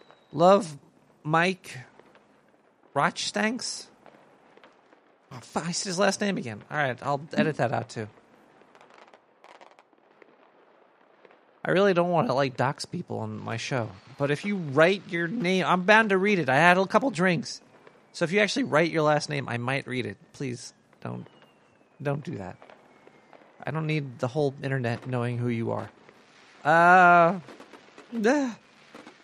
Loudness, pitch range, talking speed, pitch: -25 LUFS, 130-185 Hz, 150 wpm, 155 Hz